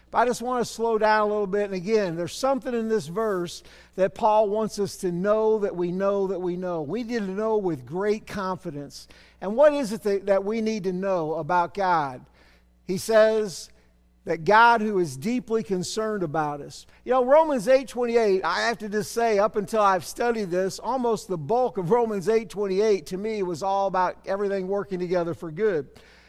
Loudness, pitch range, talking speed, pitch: -24 LUFS, 185-220 Hz, 205 wpm, 205 Hz